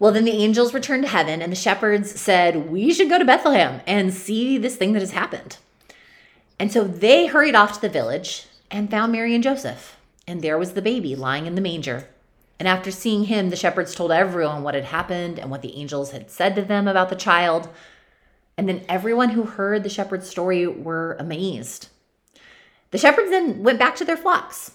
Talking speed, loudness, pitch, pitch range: 205 wpm, -20 LUFS, 190 Hz, 170-225 Hz